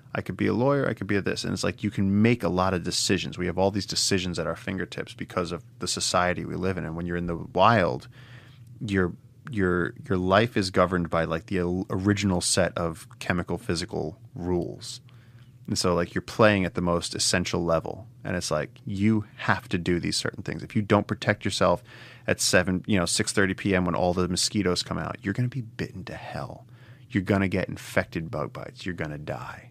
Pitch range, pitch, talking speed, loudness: 90-115 Hz, 95 Hz, 220 wpm, -26 LUFS